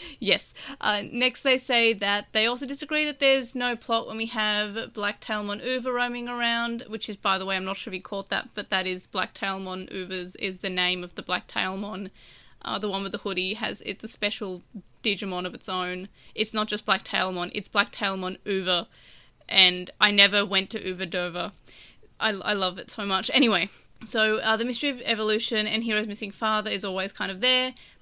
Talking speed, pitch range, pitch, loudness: 210 wpm, 190-225 Hz, 210 Hz, -25 LUFS